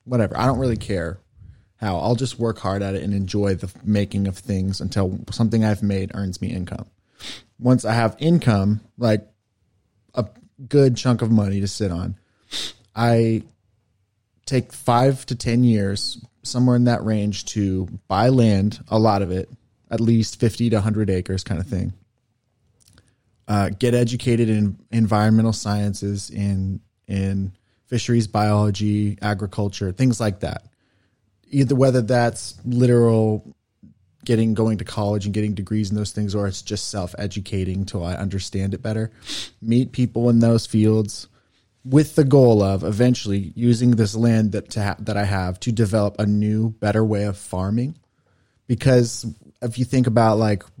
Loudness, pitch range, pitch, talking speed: -21 LUFS, 100-120 Hz, 110 Hz, 160 wpm